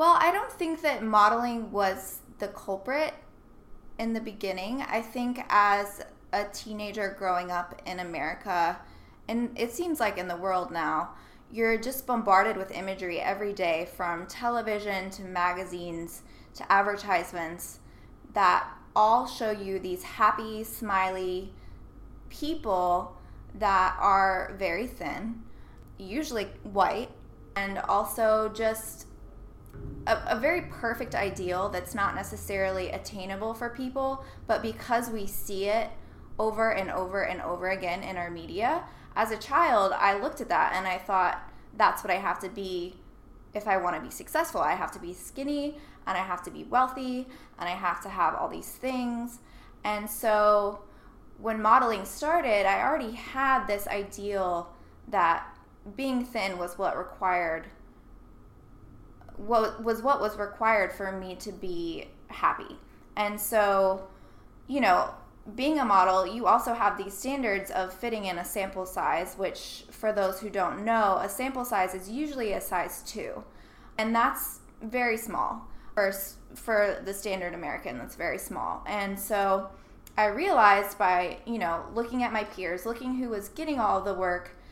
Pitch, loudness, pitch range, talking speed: 205 Hz, -29 LUFS, 185-230 Hz, 150 wpm